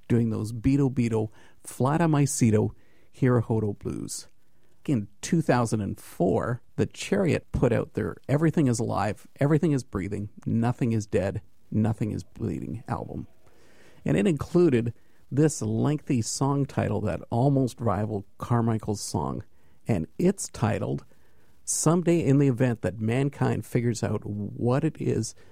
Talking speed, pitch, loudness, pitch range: 130 wpm, 115 Hz, -26 LUFS, 105-135 Hz